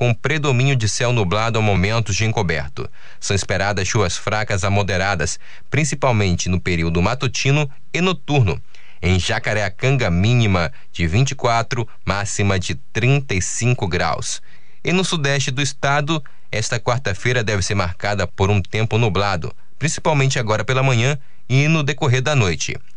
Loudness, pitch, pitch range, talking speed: -19 LUFS, 110 Hz, 95-135 Hz, 140 wpm